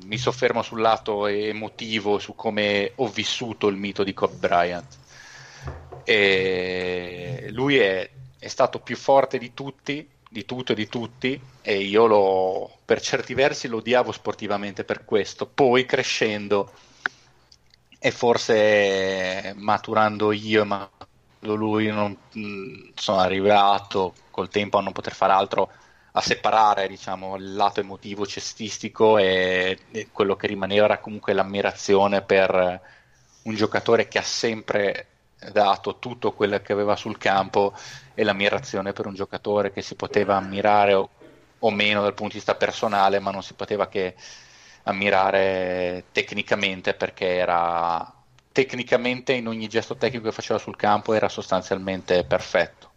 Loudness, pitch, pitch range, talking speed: -23 LUFS, 100 Hz, 95-110 Hz, 135 wpm